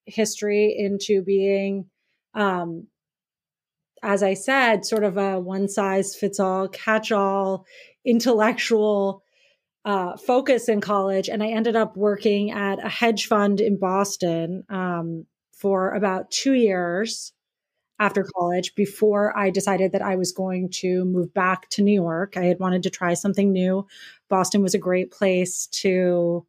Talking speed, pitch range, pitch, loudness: 145 wpm, 185-210 Hz, 195 Hz, -22 LUFS